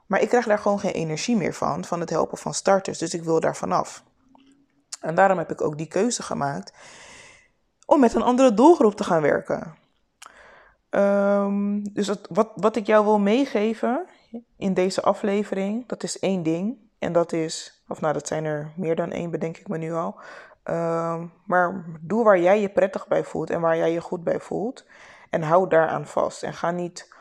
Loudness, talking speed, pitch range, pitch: -23 LUFS, 200 wpm, 165-220 Hz, 195 Hz